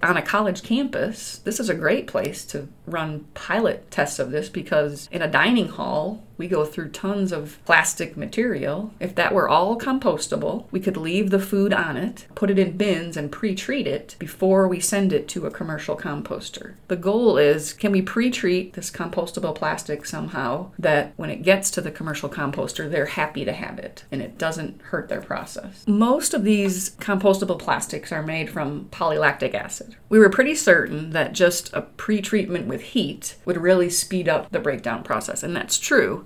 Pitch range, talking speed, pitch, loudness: 165-210 Hz, 185 wpm, 190 Hz, -22 LUFS